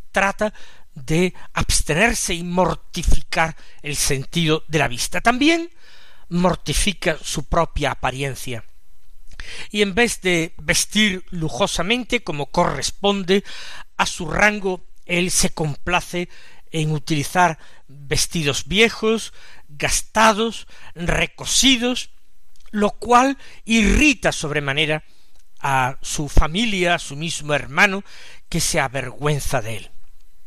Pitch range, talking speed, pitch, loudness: 145-205 Hz, 100 wpm, 170 Hz, -20 LUFS